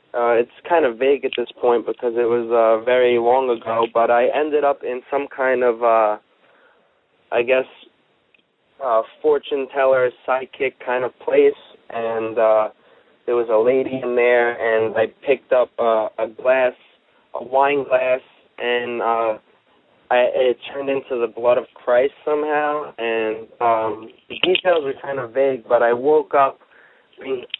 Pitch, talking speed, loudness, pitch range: 125 Hz, 165 wpm, -19 LUFS, 115-140 Hz